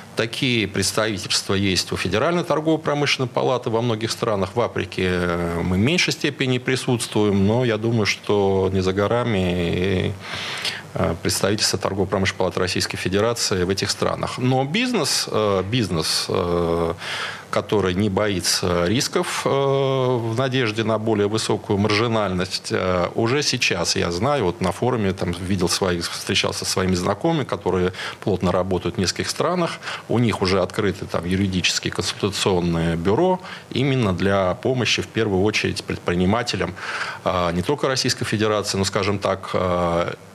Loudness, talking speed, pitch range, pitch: -21 LUFS, 130 wpm, 90-120 Hz, 100 Hz